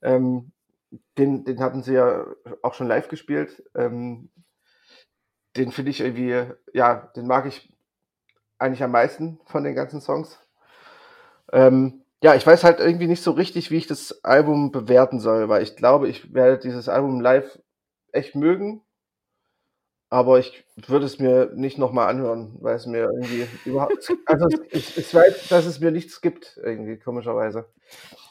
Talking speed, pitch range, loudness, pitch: 160 wpm, 125-165 Hz, -20 LUFS, 130 Hz